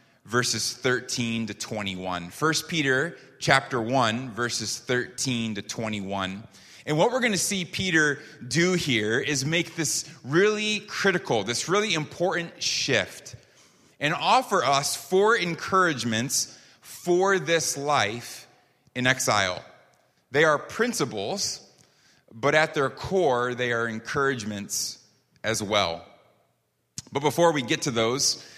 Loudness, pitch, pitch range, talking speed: -25 LUFS, 130 Hz, 115-165 Hz, 120 wpm